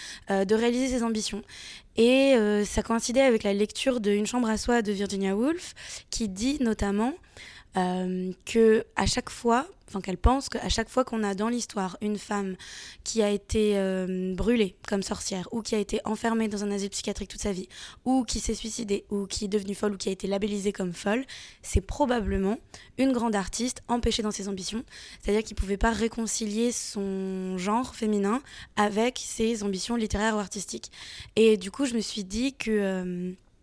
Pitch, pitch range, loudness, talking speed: 215 Hz, 200-230 Hz, -28 LUFS, 190 wpm